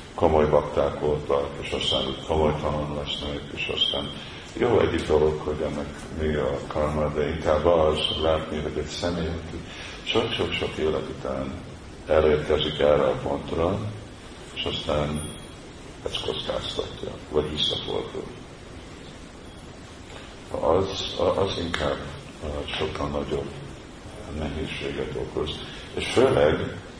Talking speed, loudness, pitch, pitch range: 105 wpm, -25 LUFS, 75 Hz, 75-80 Hz